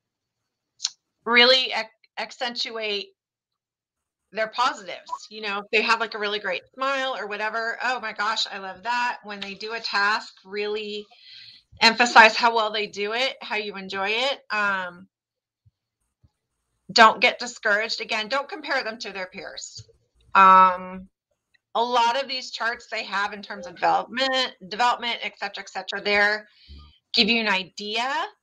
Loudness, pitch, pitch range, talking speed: -22 LUFS, 220 Hz, 200-240 Hz, 150 wpm